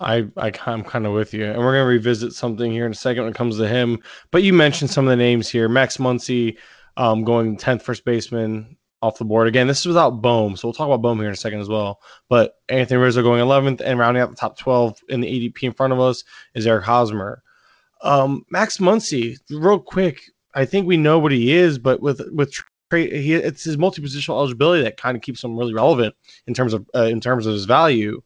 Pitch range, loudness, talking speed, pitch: 115-135 Hz, -19 LUFS, 240 wpm, 125 Hz